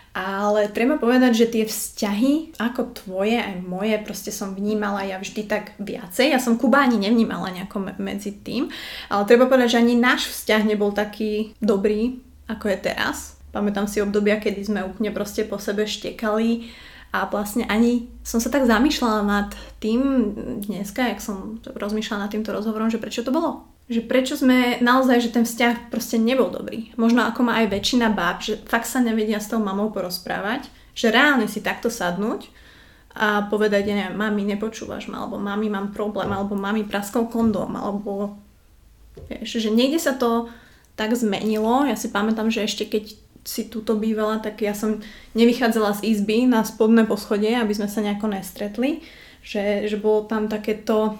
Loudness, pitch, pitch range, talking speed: -22 LUFS, 220 Hz, 205-235 Hz, 175 wpm